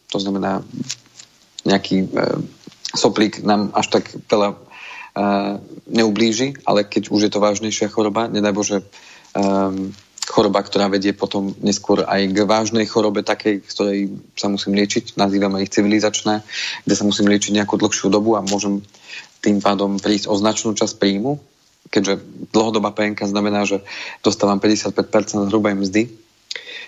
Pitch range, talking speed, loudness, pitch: 100-105 Hz, 140 wpm, -19 LUFS, 105 Hz